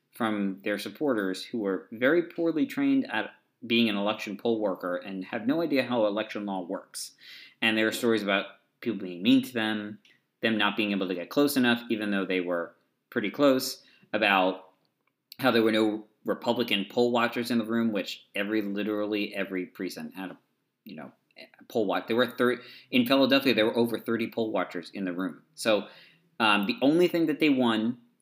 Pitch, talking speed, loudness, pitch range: 110 Hz, 195 wpm, -27 LUFS, 100-125 Hz